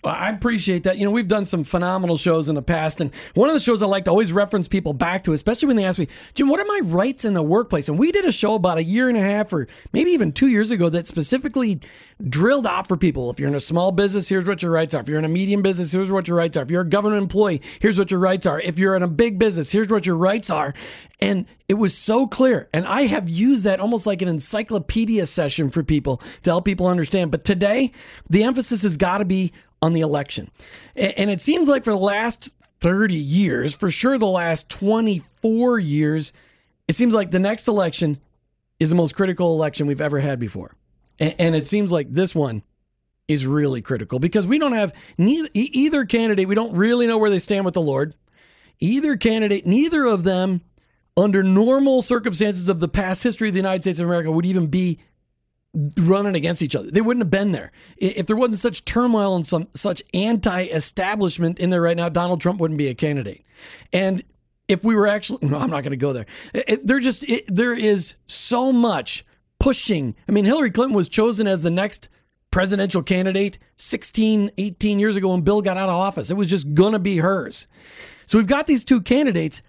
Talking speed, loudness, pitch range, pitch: 225 wpm, -20 LUFS, 170-220 Hz, 190 Hz